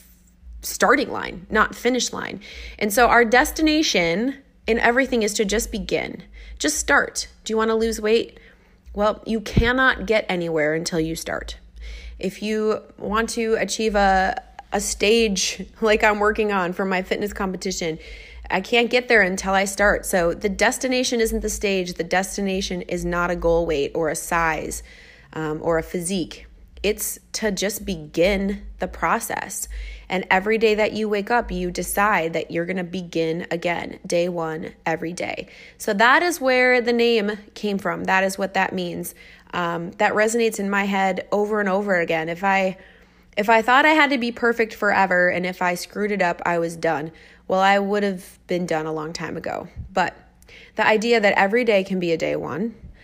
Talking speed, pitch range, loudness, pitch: 185 wpm, 175-220 Hz, -21 LUFS, 200 Hz